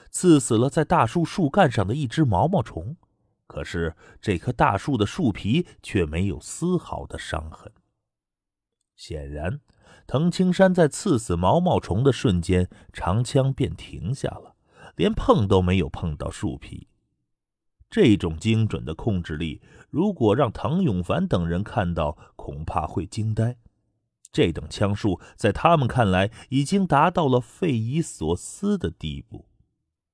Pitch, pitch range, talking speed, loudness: 110 Hz, 90-140 Hz, 210 characters per minute, -23 LUFS